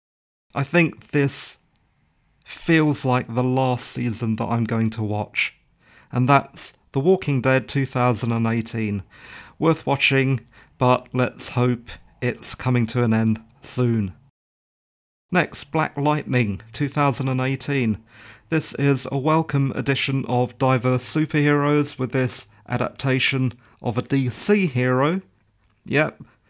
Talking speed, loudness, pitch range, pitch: 115 wpm, -22 LUFS, 115-140 Hz, 125 Hz